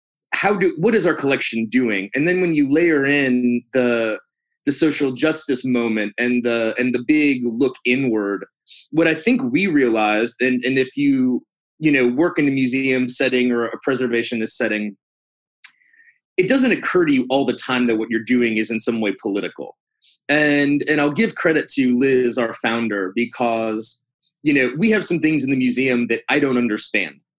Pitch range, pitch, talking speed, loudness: 115-155 Hz, 130 Hz, 185 wpm, -19 LUFS